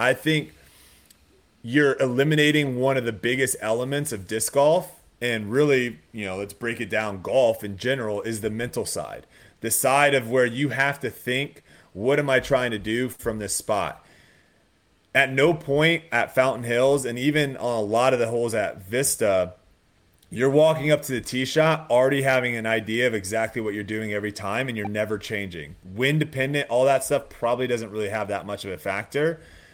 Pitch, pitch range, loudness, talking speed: 120 Hz, 105-135 Hz, -23 LUFS, 195 wpm